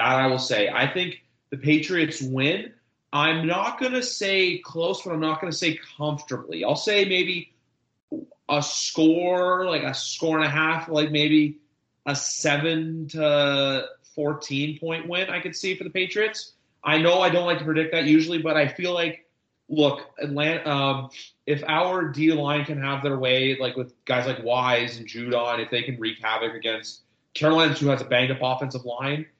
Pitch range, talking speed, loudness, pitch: 135-170 Hz, 185 wpm, -23 LUFS, 150 Hz